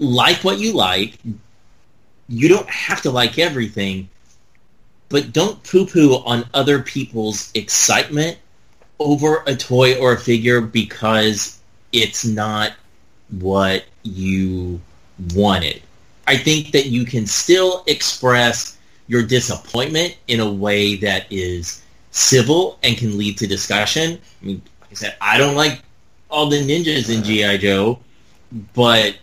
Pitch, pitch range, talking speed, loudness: 115 Hz, 105-135 Hz, 130 wpm, -16 LUFS